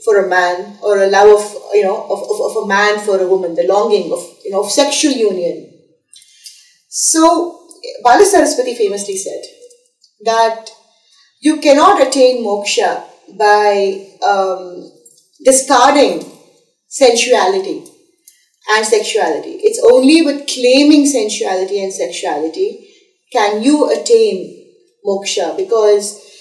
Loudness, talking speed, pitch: -12 LUFS, 120 wpm, 260 Hz